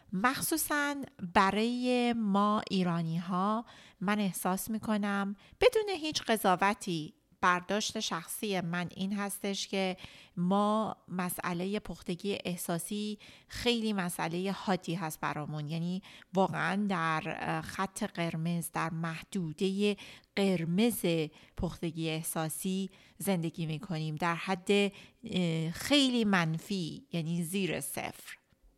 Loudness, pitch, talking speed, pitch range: -32 LUFS, 190 Hz, 100 wpm, 170-210 Hz